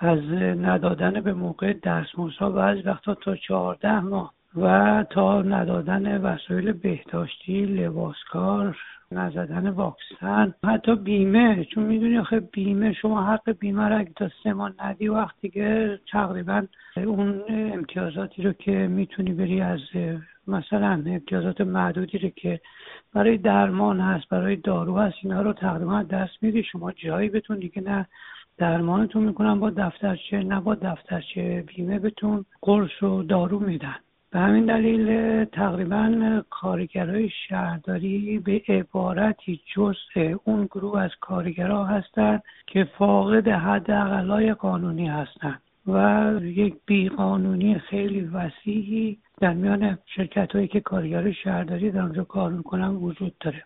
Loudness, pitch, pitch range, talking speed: -24 LUFS, 195 Hz, 180-210 Hz, 130 wpm